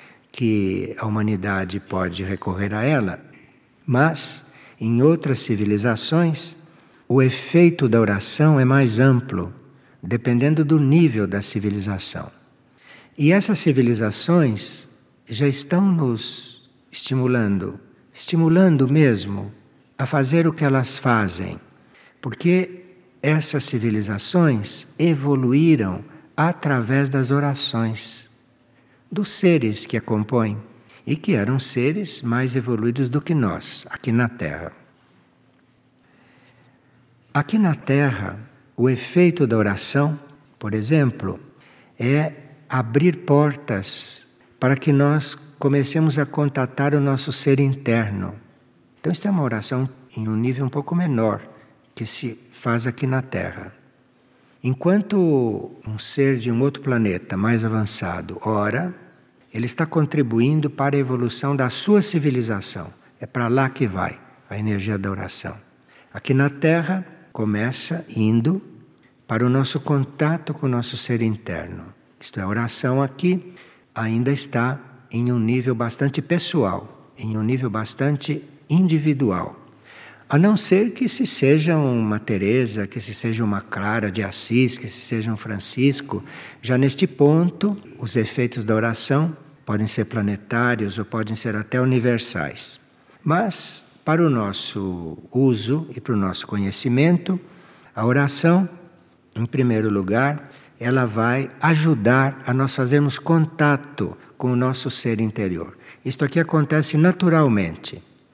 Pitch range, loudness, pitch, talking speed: 110-145 Hz, -21 LUFS, 130 Hz, 125 wpm